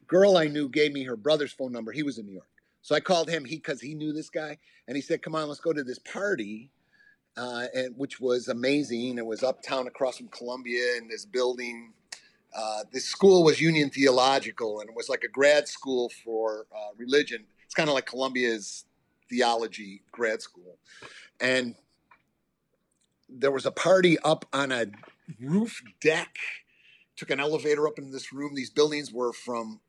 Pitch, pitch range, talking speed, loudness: 135 Hz, 120-155 Hz, 185 wpm, -27 LUFS